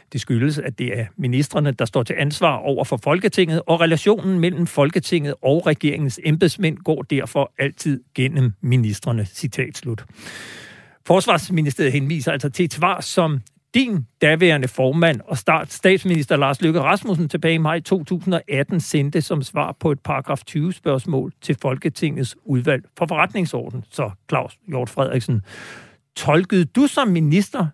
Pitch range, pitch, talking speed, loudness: 135-170 Hz, 150 Hz, 145 wpm, -20 LUFS